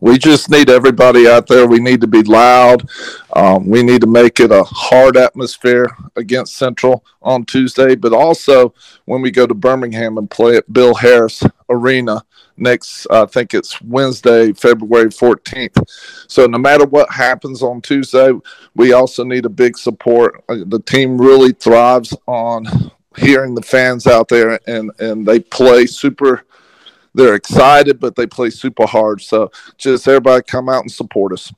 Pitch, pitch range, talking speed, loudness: 125 Hz, 115-130 Hz, 165 wpm, -10 LUFS